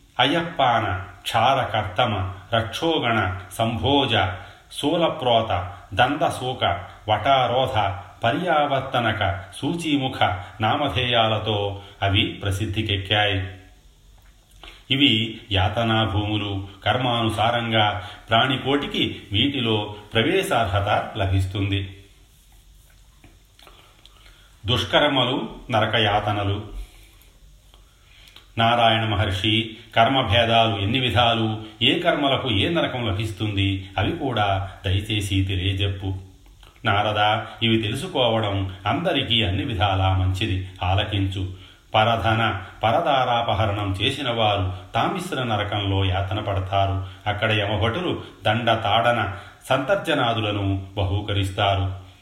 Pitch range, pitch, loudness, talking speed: 100-115 Hz, 105 Hz, -22 LUFS, 65 wpm